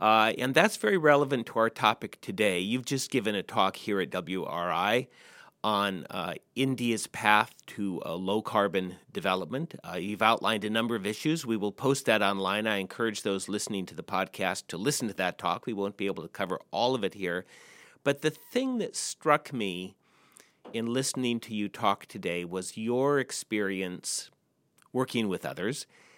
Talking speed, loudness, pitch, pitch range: 180 wpm, -29 LUFS, 110 Hz, 100-130 Hz